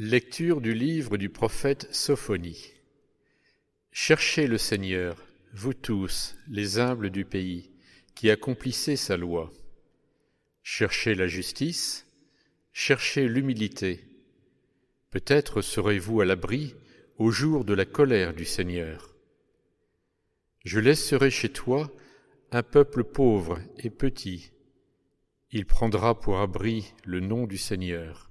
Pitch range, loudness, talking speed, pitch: 95-130 Hz, -27 LUFS, 110 wpm, 110 Hz